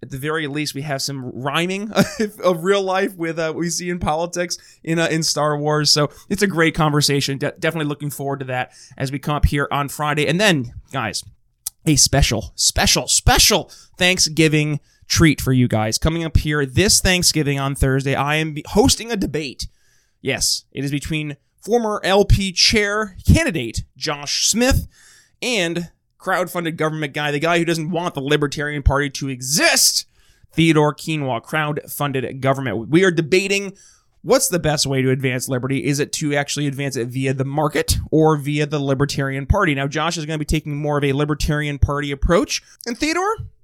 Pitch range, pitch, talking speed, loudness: 140-165 Hz, 150 Hz, 180 wpm, -19 LUFS